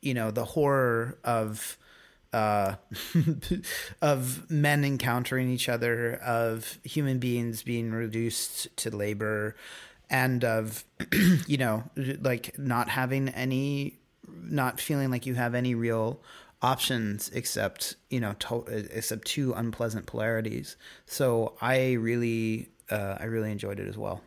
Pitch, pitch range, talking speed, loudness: 120 Hz, 110-130 Hz, 130 wpm, -29 LUFS